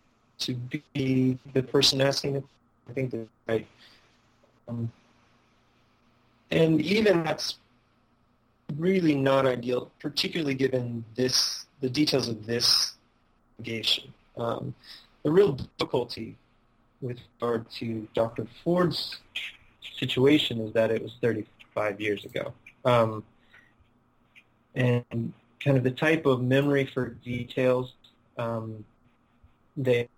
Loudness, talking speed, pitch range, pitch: -27 LUFS, 105 wpm, 115-135 Hz, 120 Hz